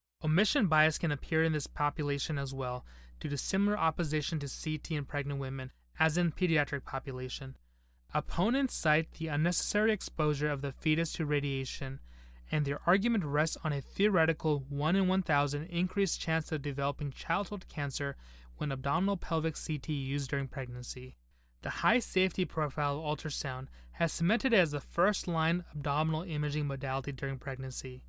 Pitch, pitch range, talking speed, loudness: 150 Hz, 140-165 Hz, 160 wpm, -32 LUFS